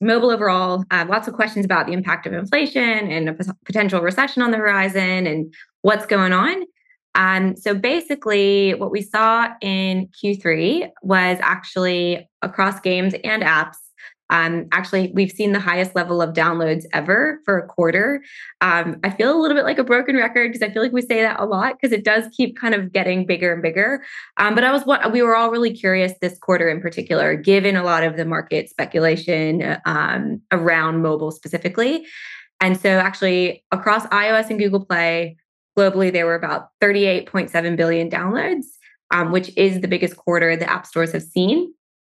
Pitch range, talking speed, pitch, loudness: 175-225 Hz, 185 wpm, 195 Hz, -18 LUFS